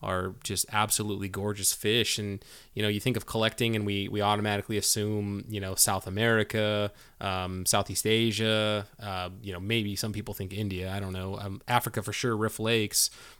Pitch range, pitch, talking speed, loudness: 100-110 Hz, 105 Hz, 185 wpm, -28 LUFS